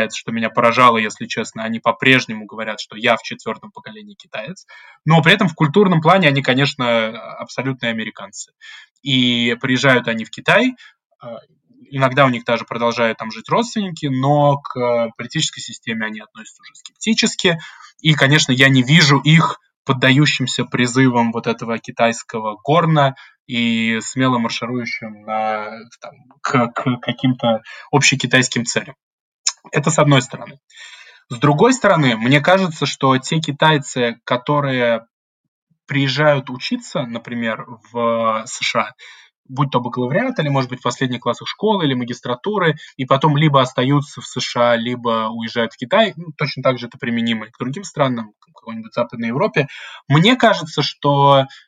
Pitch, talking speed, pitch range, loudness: 130 Hz, 145 wpm, 120-150 Hz, -17 LUFS